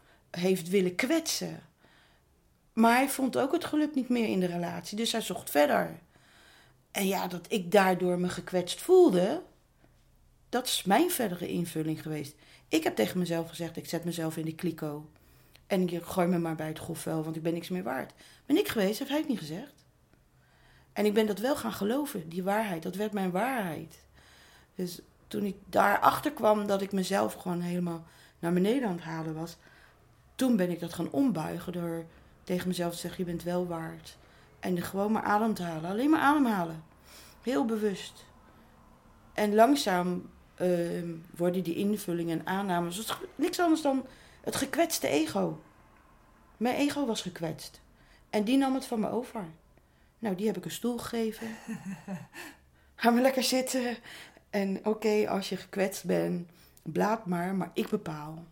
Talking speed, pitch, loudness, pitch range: 170 wpm, 190 Hz, -30 LUFS, 170-225 Hz